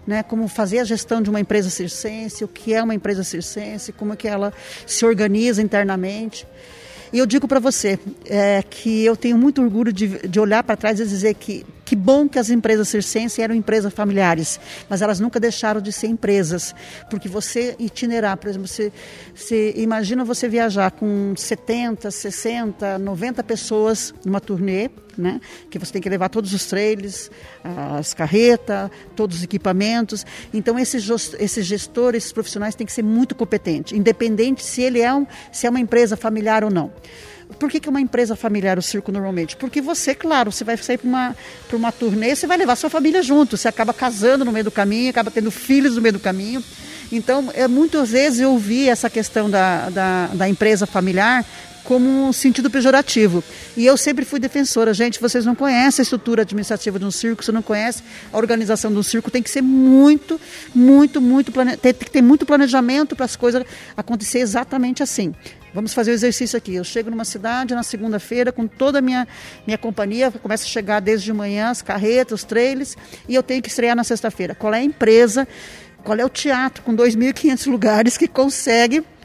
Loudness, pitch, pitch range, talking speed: -18 LUFS, 225 Hz, 210-250 Hz, 190 wpm